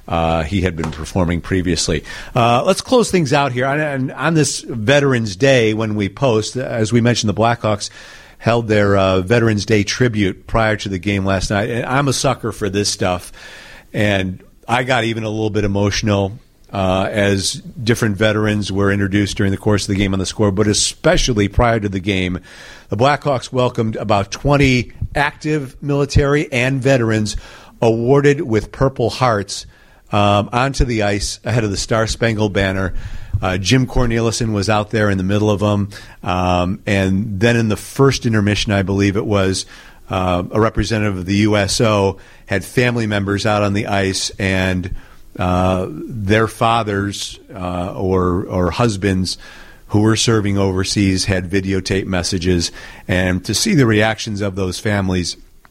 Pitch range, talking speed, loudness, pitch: 95-120 Hz, 165 wpm, -17 LUFS, 105 Hz